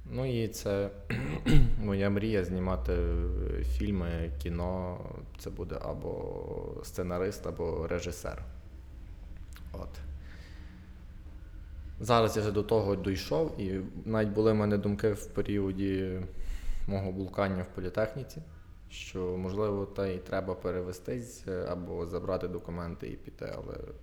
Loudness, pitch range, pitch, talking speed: -33 LUFS, 85-100 Hz, 90 Hz, 110 wpm